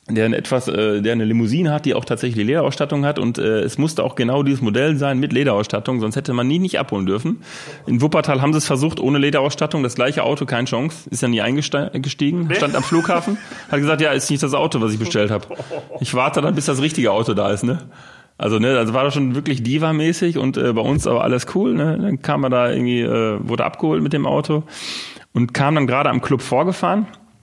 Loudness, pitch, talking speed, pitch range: -19 LUFS, 140 Hz, 235 wpm, 120-150 Hz